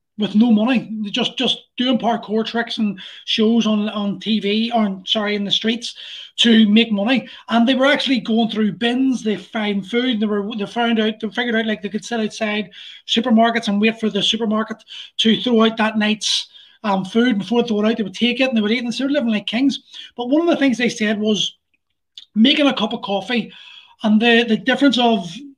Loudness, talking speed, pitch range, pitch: -18 LUFS, 225 wpm, 215-240 Hz, 225 Hz